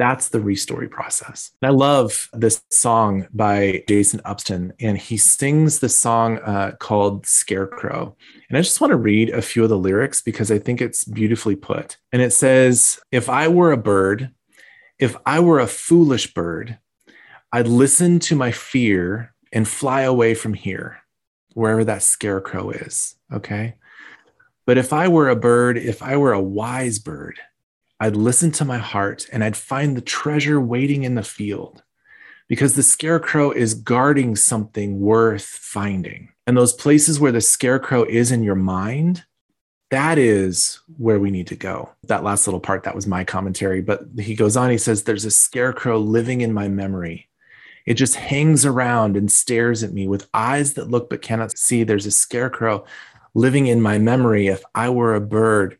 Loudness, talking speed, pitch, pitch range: -18 LUFS, 175 wpm, 115 Hz, 105-130 Hz